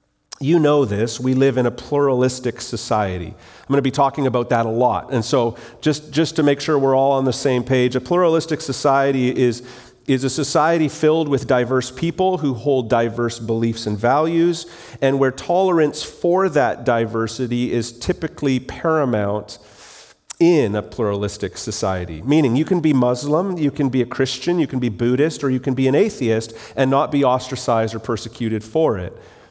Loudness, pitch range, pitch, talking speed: -19 LUFS, 120-150 Hz, 130 Hz, 180 wpm